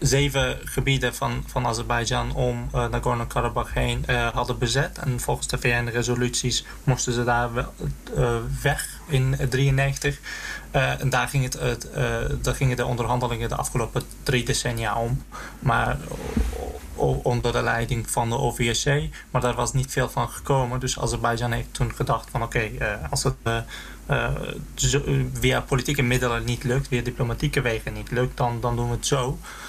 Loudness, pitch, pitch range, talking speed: -25 LUFS, 125 Hz, 120-135 Hz, 170 wpm